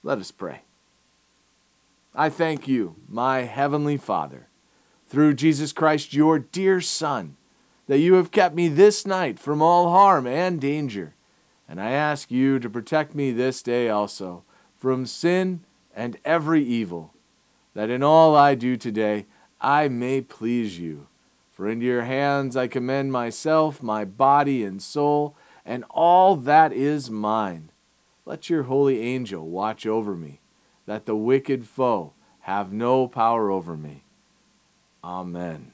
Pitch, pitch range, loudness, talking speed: 130 Hz, 110-155 Hz, -22 LUFS, 145 wpm